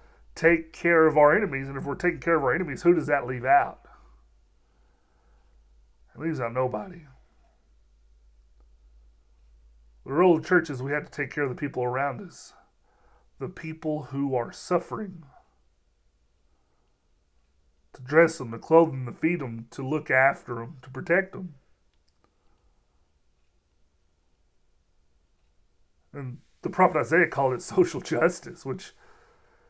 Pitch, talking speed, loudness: 130 Hz, 135 wpm, -25 LUFS